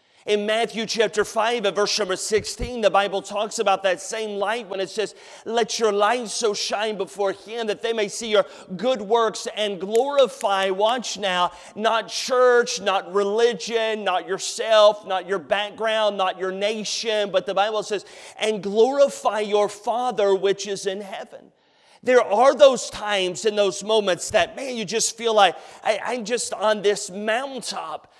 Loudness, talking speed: -22 LUFS, 170 wpm